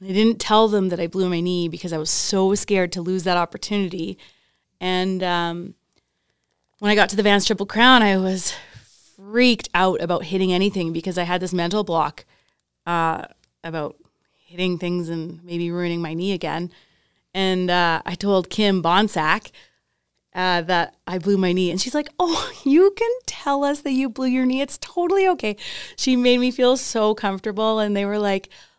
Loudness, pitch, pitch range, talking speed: -20 LUFS, 190 Hz, 175-220 Hz, 185 wpm